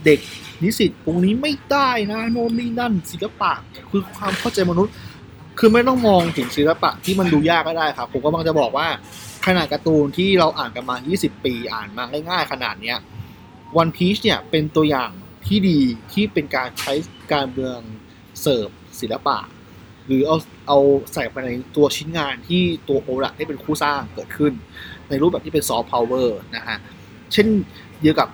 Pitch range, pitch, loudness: 135-190 Hz, 155 Hz, -20 LUFS